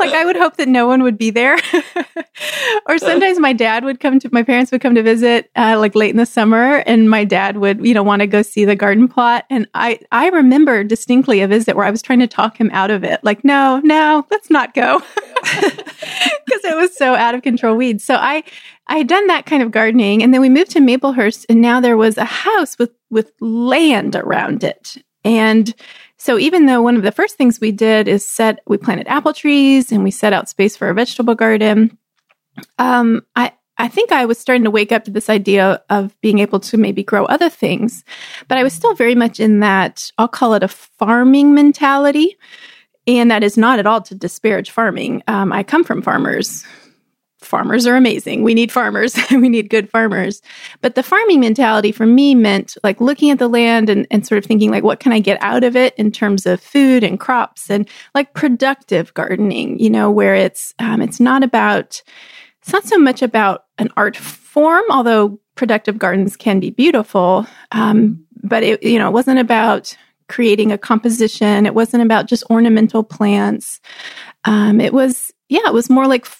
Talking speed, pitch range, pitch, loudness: 210 wpm, 215-265 Hz, 235 Hz, -13 LUFS